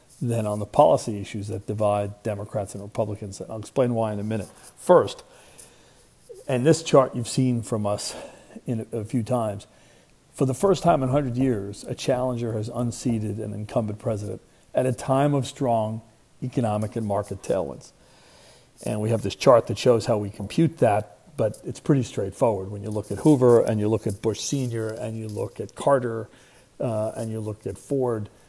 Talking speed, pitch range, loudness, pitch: 190 wpm, 105-130 Hz, -24 LUFS, 115 Hz